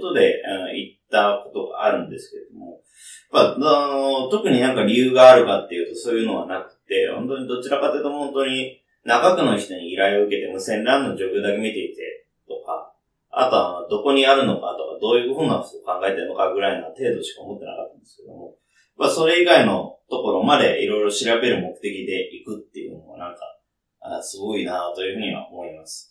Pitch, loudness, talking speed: 165 Hz, -20 LUFS, 425 characters per minute